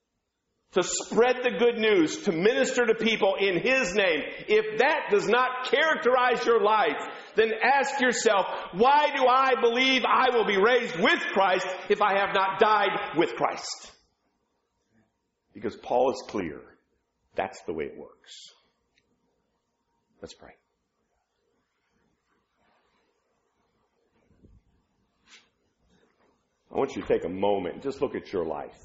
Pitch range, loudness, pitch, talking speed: 215-315 Hz, -24 LUFS, 250 Hz, 130 wpm